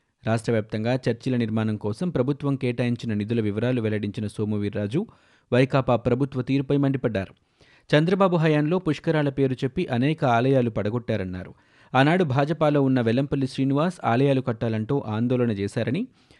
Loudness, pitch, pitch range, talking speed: -24 LUFS, 125 Hz, 110-140 Hz, 115 wpm